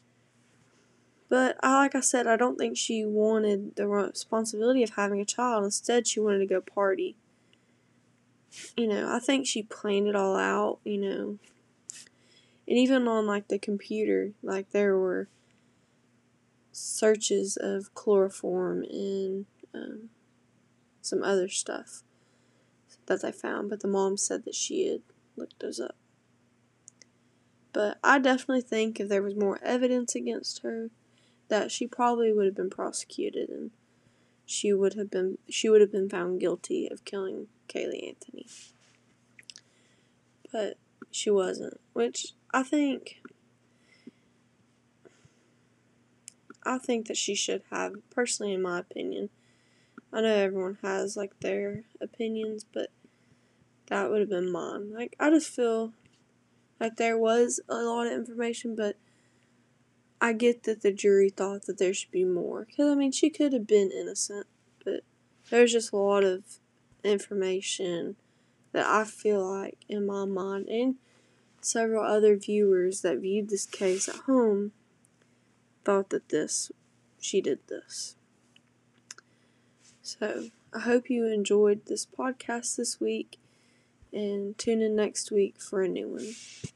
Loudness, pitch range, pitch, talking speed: -29 LUFS, 195-240 Hz, 210 Hz, 140 wpm